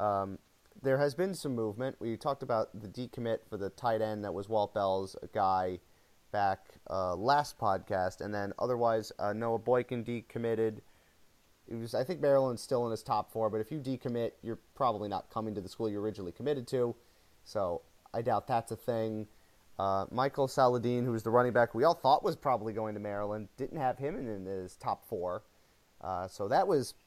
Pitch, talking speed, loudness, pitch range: 110 Hz, 195 wpm, -33 LUFS, 100-125 Hz